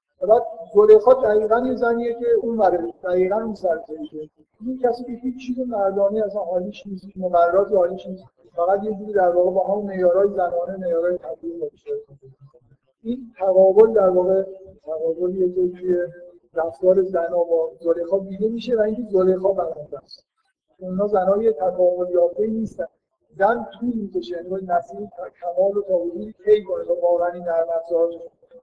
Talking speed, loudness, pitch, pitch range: 155 wpm, -20 LUFS, 190 Hz, 175-220 Hz